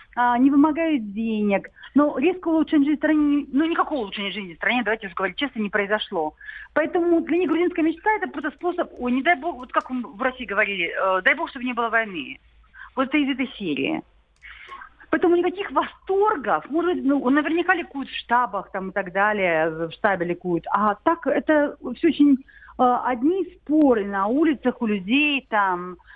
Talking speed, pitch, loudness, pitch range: 180 wpm, 270 Hz, -22 LUFS, 210-320 Hz